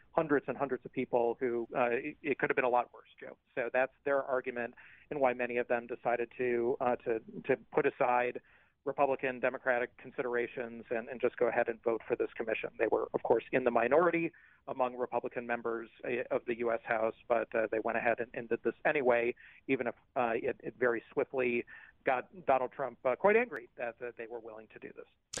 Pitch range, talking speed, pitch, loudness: 120-140 Hz, 210 wpm, 125 Hz, -33 LUFS